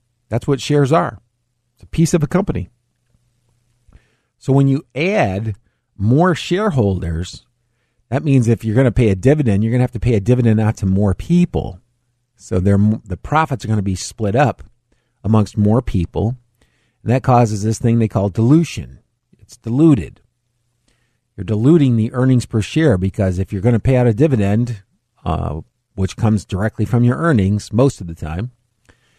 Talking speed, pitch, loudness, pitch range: 175 wpm, 120 Hz, -16 LUFS, 105-125 Hz